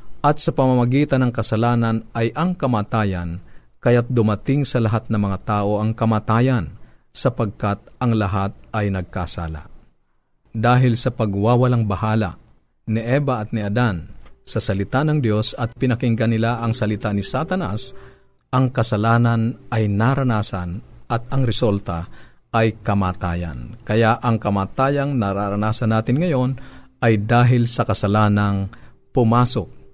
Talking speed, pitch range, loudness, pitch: 125 wpm, 105-125 Hz, -20 LUFS, 115 Hz